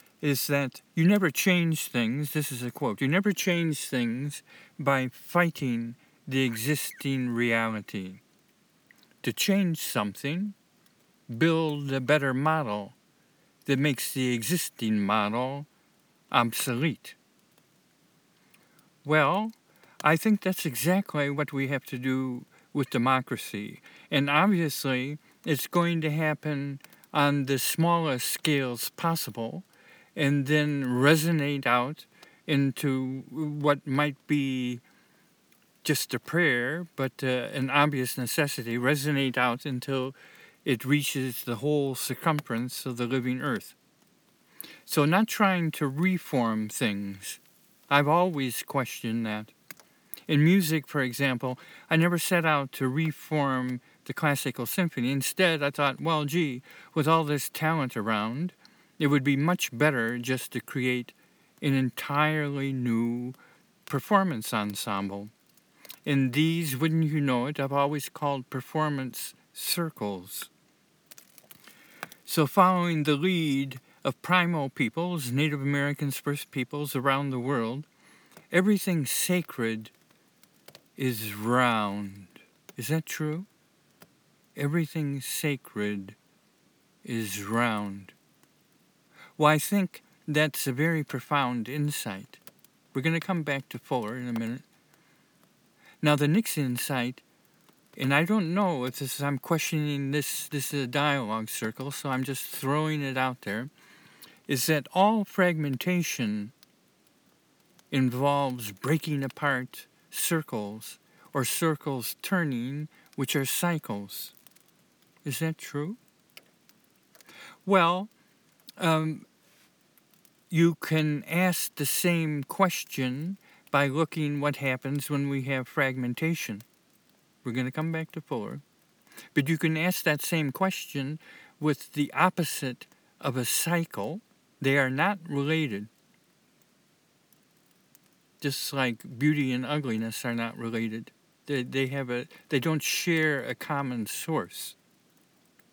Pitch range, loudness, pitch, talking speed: 130-160 Hz, -28 LUFS, 145 Hz, 115 wpm